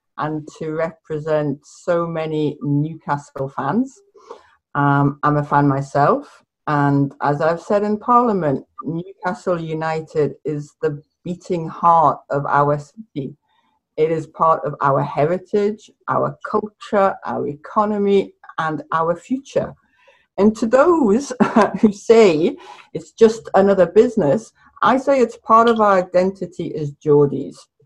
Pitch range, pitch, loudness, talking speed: 150-210 Hz, 170 Hz, -18 LUFS, 125 wpm